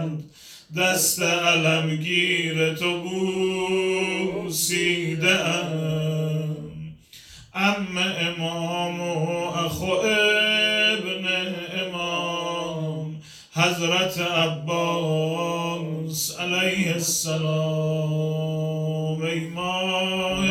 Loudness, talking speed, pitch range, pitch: -23 LUFS, 45 wpm, 160-185 Hz, 170 Hz